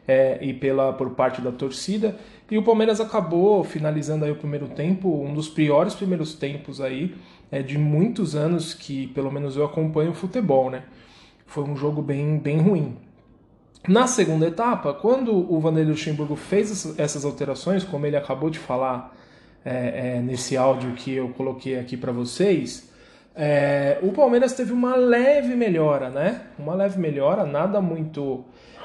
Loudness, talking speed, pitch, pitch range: -23 LUFS, 160 wpm, 150 Hz, 135-190 Hz